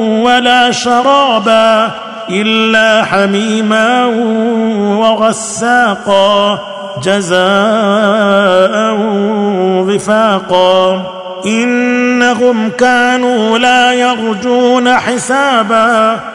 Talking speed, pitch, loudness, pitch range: 45 wpm, 220 Hz, -10 LUFS, 200-245 Hz